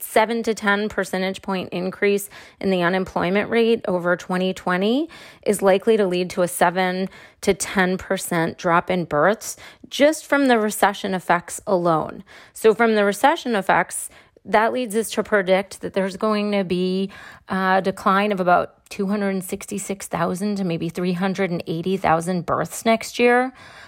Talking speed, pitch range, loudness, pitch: 145 wpm, 185-215 Hz, -21 LUFS, 195 Hz